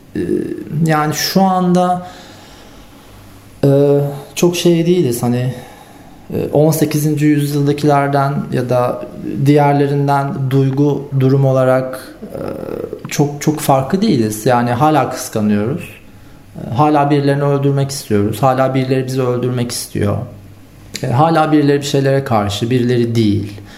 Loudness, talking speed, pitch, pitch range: -15 LUFS, 95 wpm, 140 Hz, 125-150 Hz